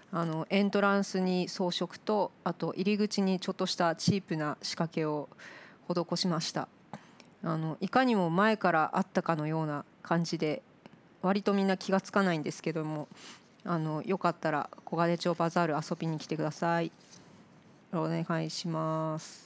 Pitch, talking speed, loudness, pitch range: 170 Hz, 320 characters per minute, -31 LUFS, 160-190 Hz